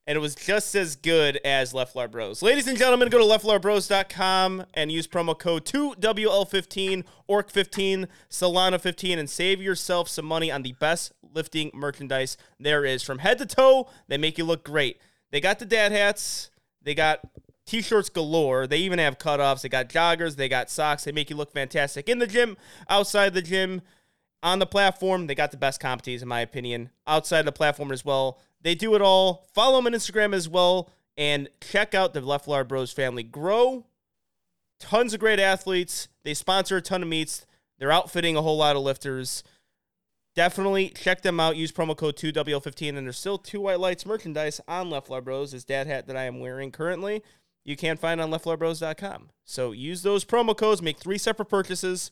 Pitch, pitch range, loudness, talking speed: 165 Hz, 145-195 Hz, -25 LUFS, 190 wpm